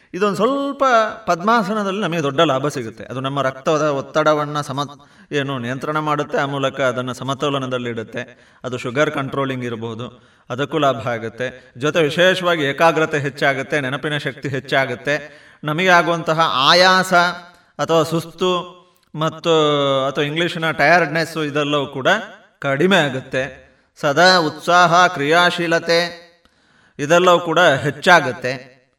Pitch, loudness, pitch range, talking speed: 150 Hz, -17 LUFS, 135-175 Hz, 110 wpm